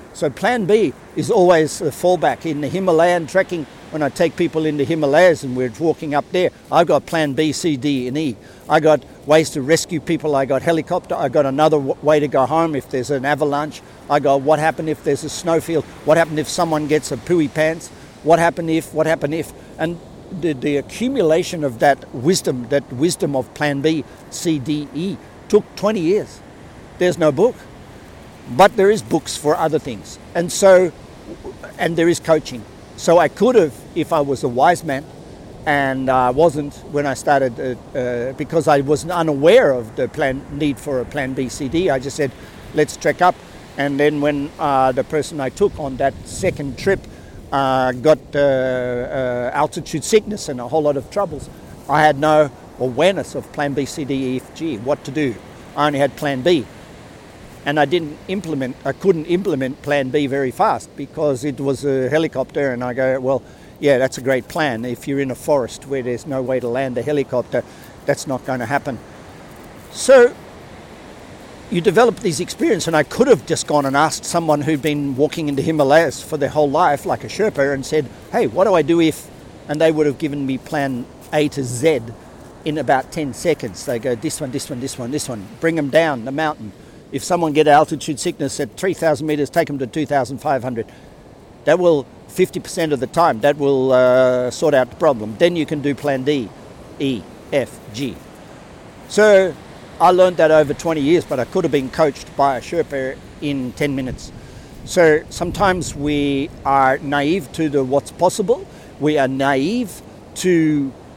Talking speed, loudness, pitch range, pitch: 195 wpm, -18 LUFS, 135-160 Hz, 150 Hz